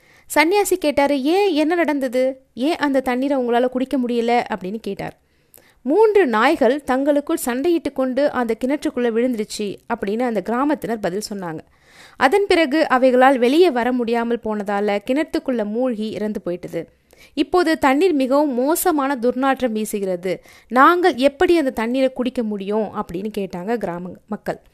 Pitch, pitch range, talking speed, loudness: 255 Hz, 215-295 Hz, 130 wpm, -19 LUFS